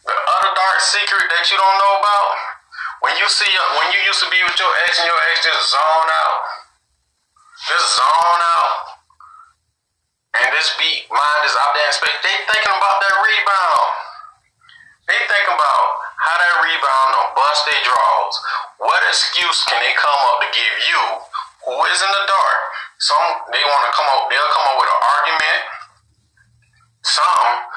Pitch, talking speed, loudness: 200 Hz, 175 wpm, -14 LUFS